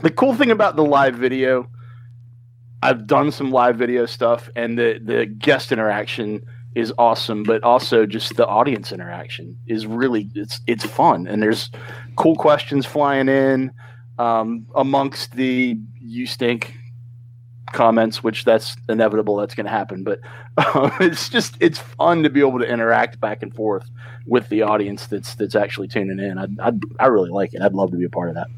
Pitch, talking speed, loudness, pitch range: 120 Hz, 180 wpm, -19 LUFS, 110-130 Hz